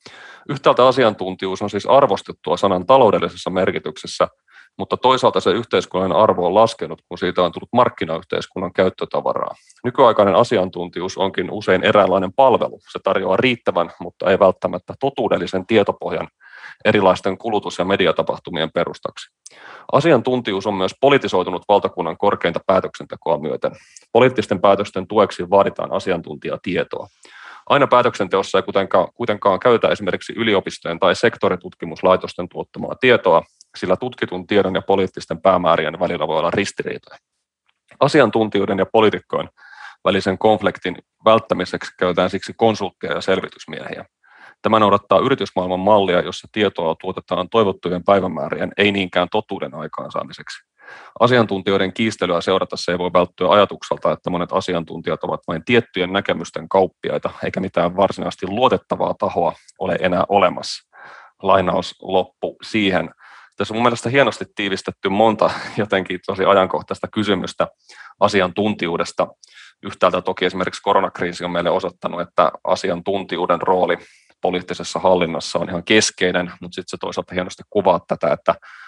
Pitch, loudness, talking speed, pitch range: 95 Hz, -18 LUFS, 120 wpm, 90-105 Hz